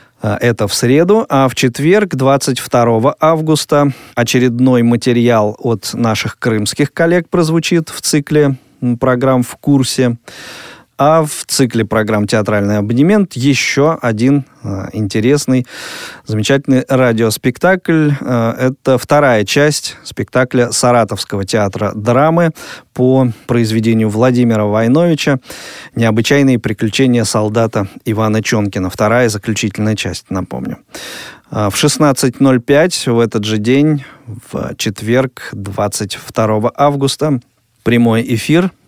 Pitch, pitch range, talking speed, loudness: 125 Hz, 110-140 Hz, 100 wpm, -13 LUFS